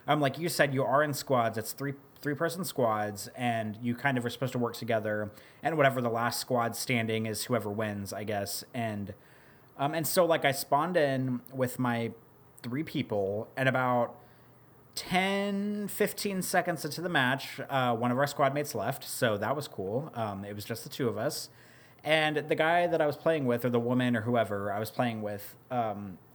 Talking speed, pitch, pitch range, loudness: 205 wpm, 125 Hz, 115-145 Hz, -30 LUFS